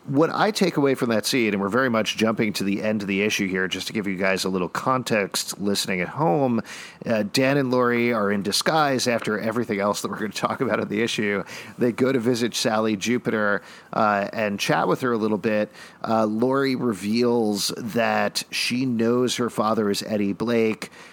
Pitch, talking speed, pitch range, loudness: 110 Hz, 210 wpm, 100-120 Hz, -23 LUFS